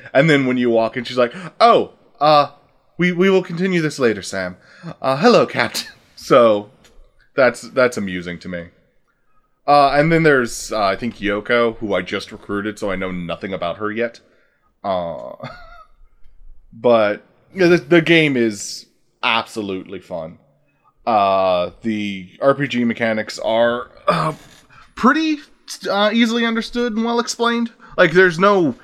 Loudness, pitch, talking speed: -17 LUFS, 120 Hz, 145 wpm